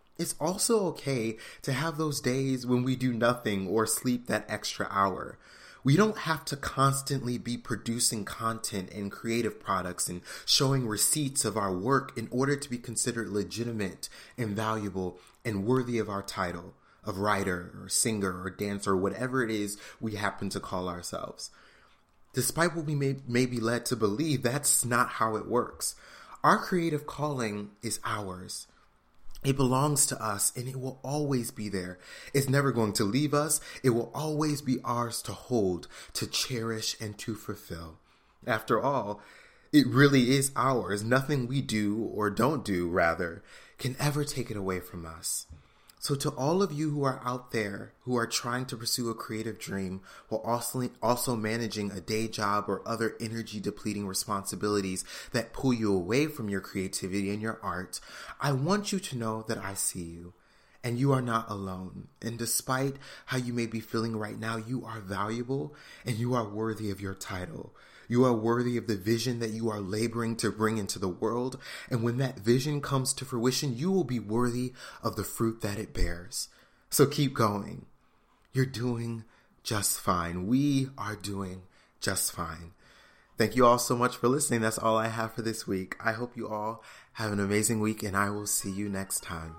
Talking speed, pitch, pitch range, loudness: 185 wpm, 115 Hz, 105-130 Hz, -30 LUFS